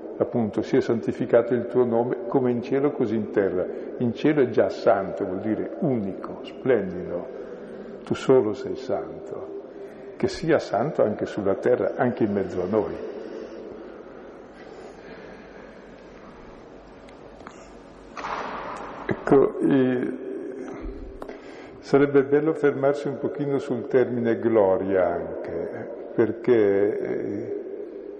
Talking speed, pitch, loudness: 100 wpm, 145 Hz, -24 LUFS